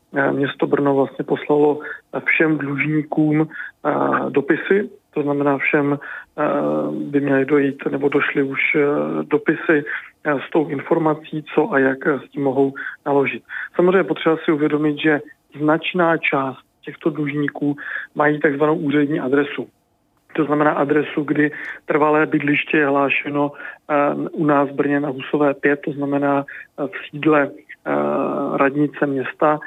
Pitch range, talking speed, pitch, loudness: 140-155 Hz, 125 wpm, 145 Hz, -19 LUFS